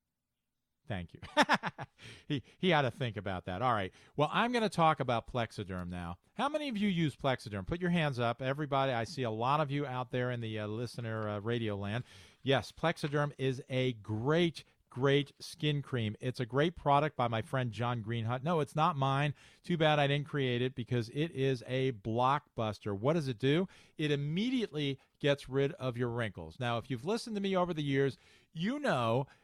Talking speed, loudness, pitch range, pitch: 200 wpm, -34 LUFS, 115-150 Hz, 135 Hz